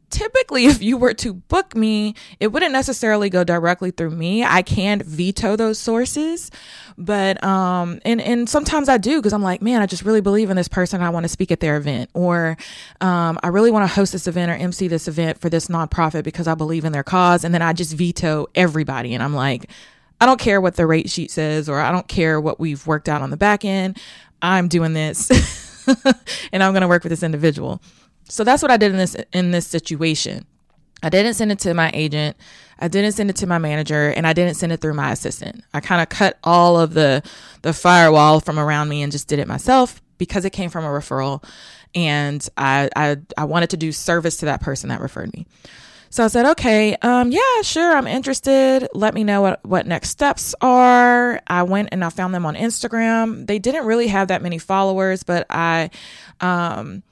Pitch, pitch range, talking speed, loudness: 180 Hz, 160-215 Hz, 220 wpm, -18 LUFS